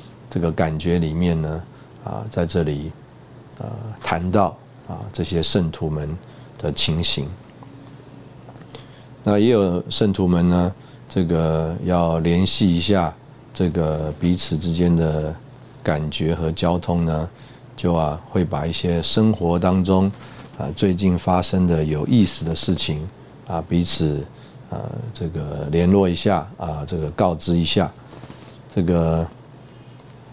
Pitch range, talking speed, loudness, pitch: 80-110 Hz, 180 characters per minute, -21 LUFS, 90 Hz